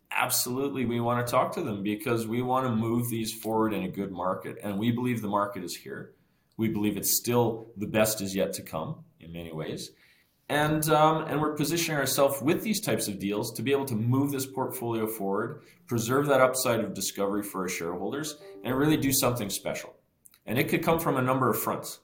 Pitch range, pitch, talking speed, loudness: 105-140 Hz, 120 Hz, 215 wpm, -28 LUFS